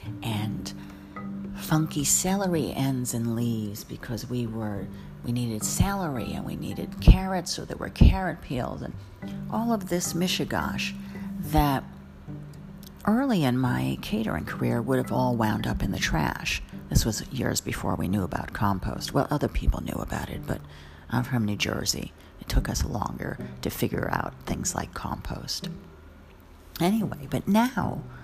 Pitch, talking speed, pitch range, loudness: 110 Hz, 155 wpm, 95-150 Hz, -28 LUFS